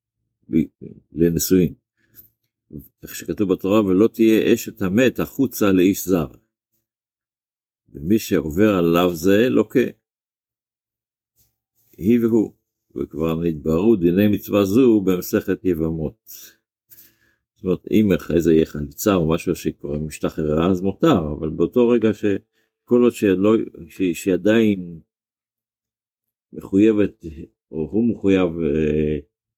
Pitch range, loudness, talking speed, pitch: 85-110 Hz, -19 LUFS, 100 wpm, 105 Hz